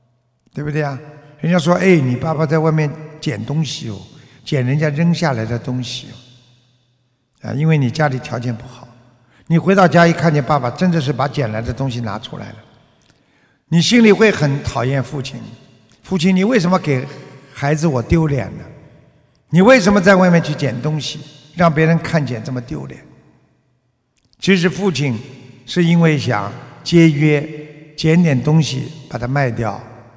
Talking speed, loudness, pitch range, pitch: 240 characters per minute, -16 LUFS, 125-160 Hz, 145 Hz